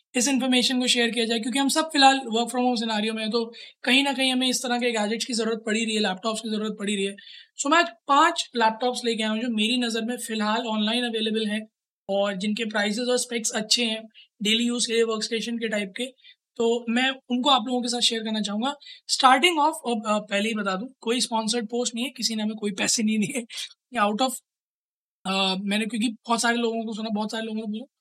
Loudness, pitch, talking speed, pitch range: -24 LUFS, 230 Hz, 235 wpm, 220-250 Hz